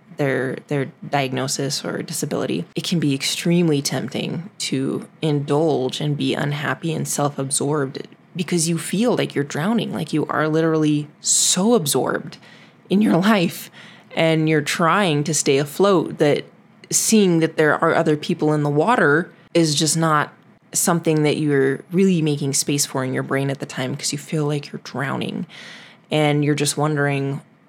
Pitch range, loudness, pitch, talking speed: 145-170 Hz, -20 LUFS, 155 Hz, 165 wpm